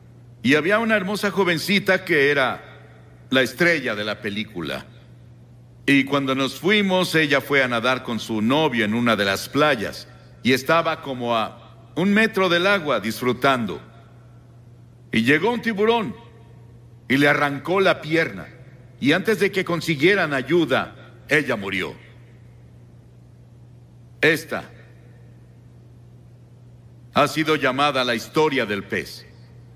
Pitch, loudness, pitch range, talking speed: 125 Hz, -20 LUFS, 120-160 Hz, 125 wpm